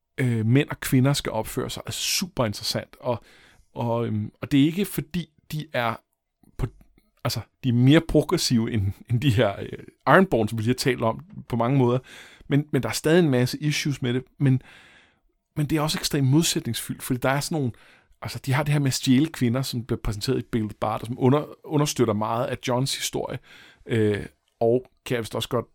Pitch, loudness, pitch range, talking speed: 130 Hz, -24 LUFS, 115-145 Hz, 205 wpm